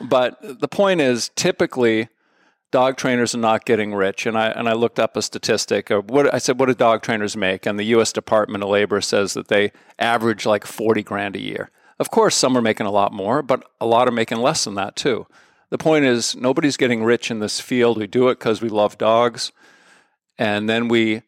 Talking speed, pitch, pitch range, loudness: 220 wpm, 115 Hz, 105-125 Hz, -19 LUFS